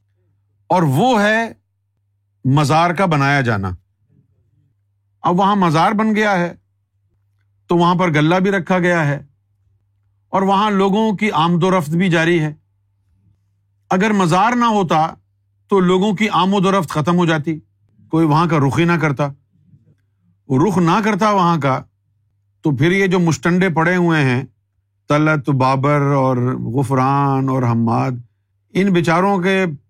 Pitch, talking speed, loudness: 145 Hz, 150 wpm, -16 LUFS